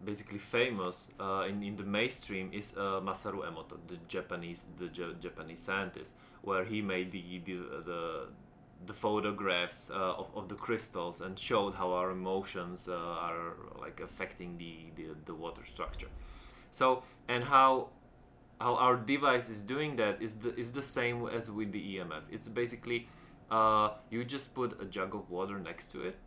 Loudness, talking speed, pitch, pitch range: -35 LUFS, 170 wpm, 105 Hz, 90-120 Hz